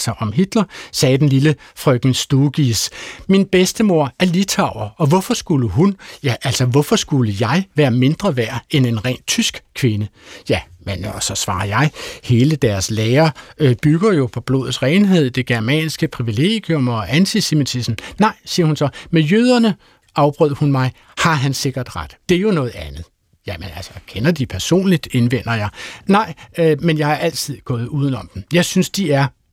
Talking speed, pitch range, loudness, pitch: 175 wpm, 120-170 Hz, -17 LUFS, 140 Hz